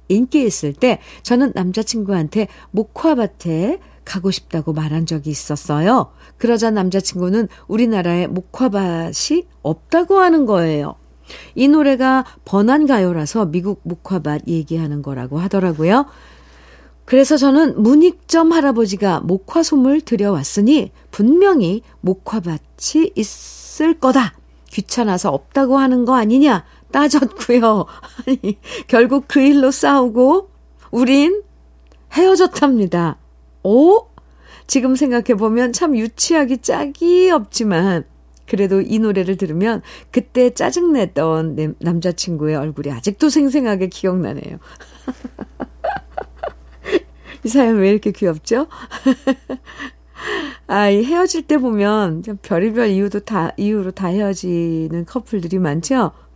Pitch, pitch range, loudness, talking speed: 220 Hz, 180-270 Hz, -16 LUFS, 260 characters per minute